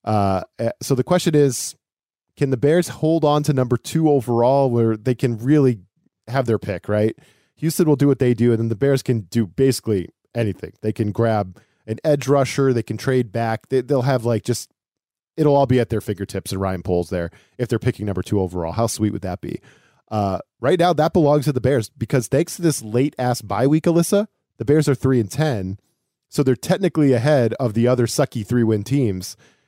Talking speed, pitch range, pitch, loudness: 215 wpm, 110-145 Hz, 125 Hz, -20 LUFS